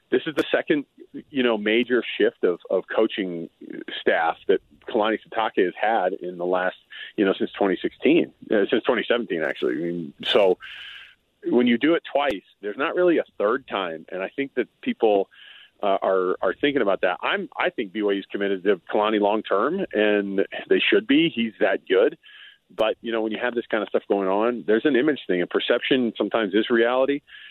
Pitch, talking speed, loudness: 120 Hz, 200 wpm, -23 LUFS